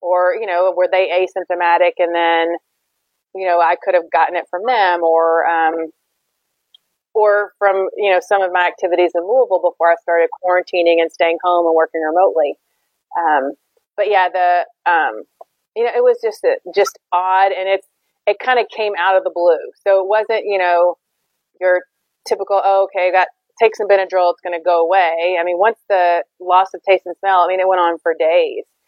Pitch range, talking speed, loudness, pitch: 175-200 Hz, 195 wpm, -16 LUFS, 180 Hz